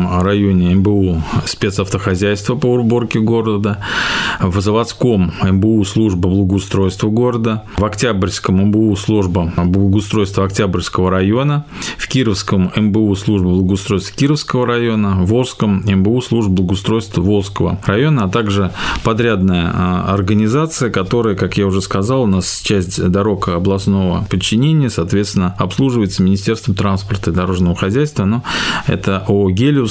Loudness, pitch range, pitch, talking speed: -15 LUFS, 95-115 Hz, 100 Hz, 120 wpm